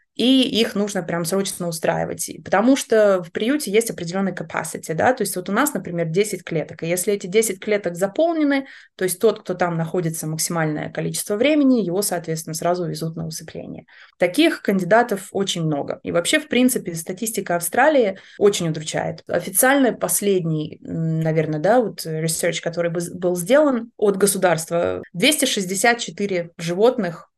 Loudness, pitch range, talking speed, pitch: -20 LUFS, 170-225 Hz, 150 wpm, 190 Hz